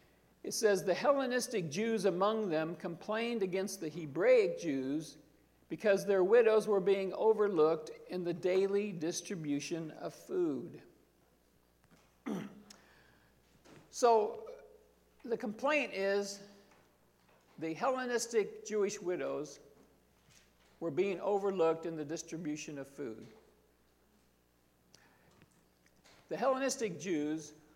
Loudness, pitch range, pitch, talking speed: -34 LUFS, 150-215 Hz, 185 Hz, 95 wpm